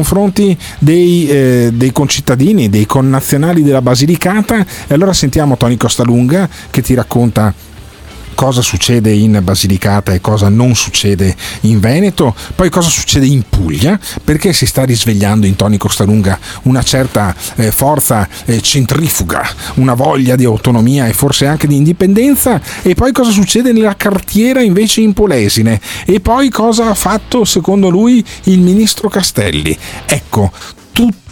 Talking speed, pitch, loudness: 140 wpm, 135 Hz, -10 LUFS